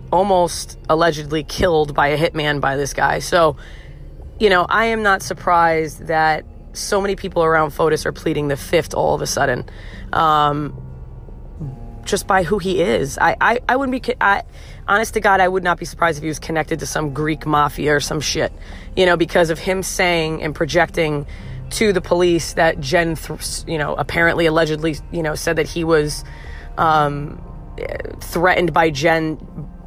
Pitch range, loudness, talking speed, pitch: 150-175 Hz, -18 LUFS, 180 wpm, 160 Hz